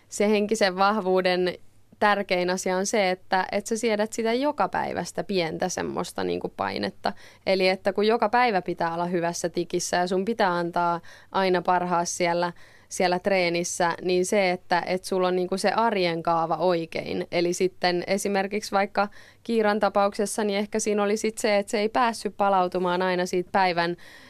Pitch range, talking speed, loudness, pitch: 175-205 Hz, 170 wpm, -25 LUFS, 185 Hz